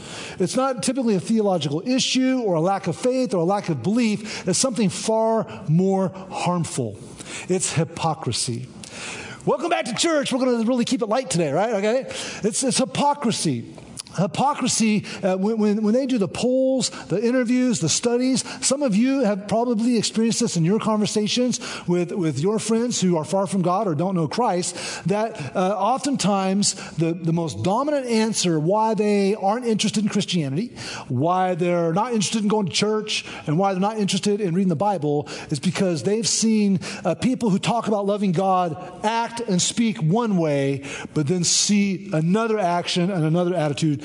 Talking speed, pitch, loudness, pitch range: 180 wpm, 200 Hz, -22 LUFS, 175-225 Hz